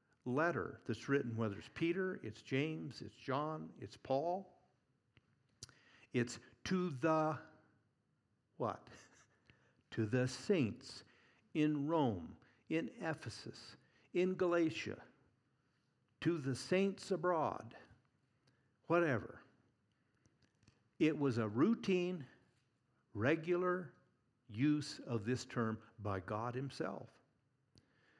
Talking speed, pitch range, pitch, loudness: 90 wpm, 120-160 Hz, 135 Hz, -39 LUFS